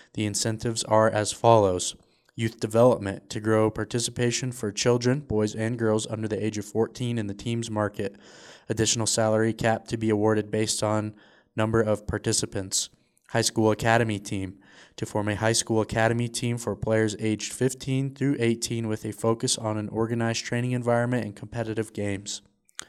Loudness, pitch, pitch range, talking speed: -26 LUFS, 110 Hz, 105-115 Hz, 165 wpm